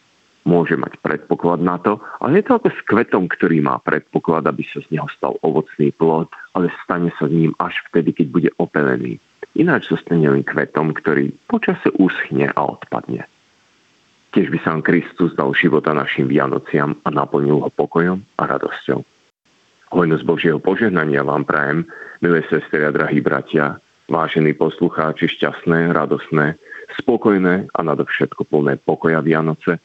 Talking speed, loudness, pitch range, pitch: 150 wpm, -18 LUFS, 75-90 Hz, 80 Hz